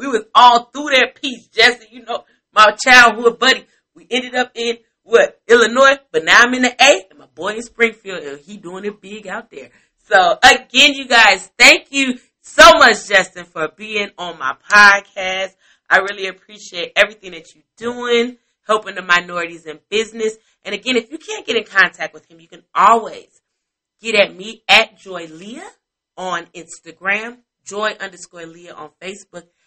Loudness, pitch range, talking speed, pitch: -13 LUFS, 185-245 Hz, 180 wpm, 215 Hz